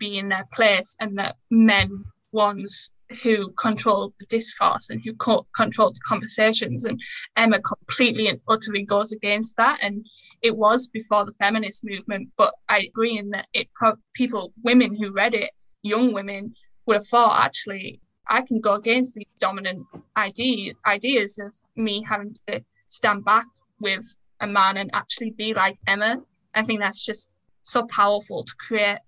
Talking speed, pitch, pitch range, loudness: 165 wpm, 215 Hz, 205-230 Hz, -22 LUFS